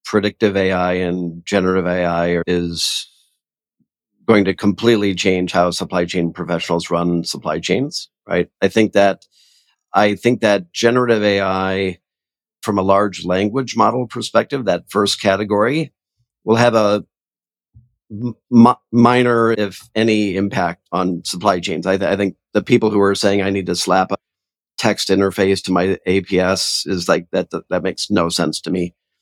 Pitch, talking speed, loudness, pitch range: 100 Hz, 155 wpm, -17 LUFS, 90-110 Hz